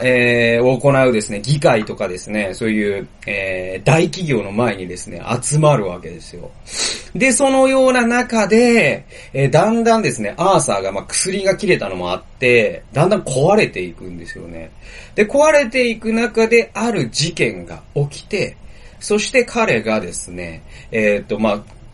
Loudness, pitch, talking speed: -16 LUFS, 135 Hz, 315 characters per minute